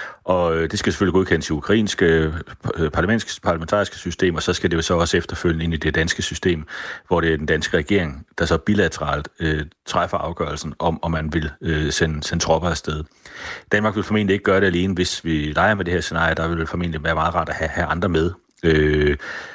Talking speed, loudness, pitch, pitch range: 215 wpm, -21 LUFS, 85 Hz, 80-90 Hz